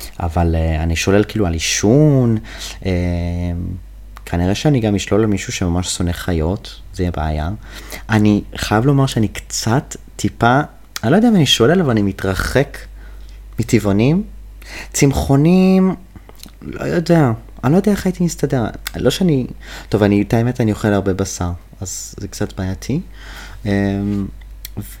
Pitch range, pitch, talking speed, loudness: 95-125 Hz, 105 Hz, 145 wpm, -17 LUFS